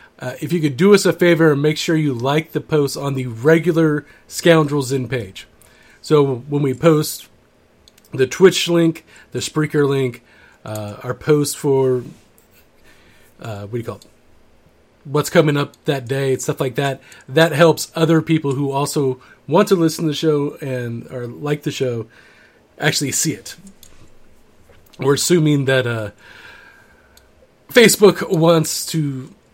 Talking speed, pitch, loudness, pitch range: 155 wpm, 145 Hz, -17 LUFS, 130-160 Hz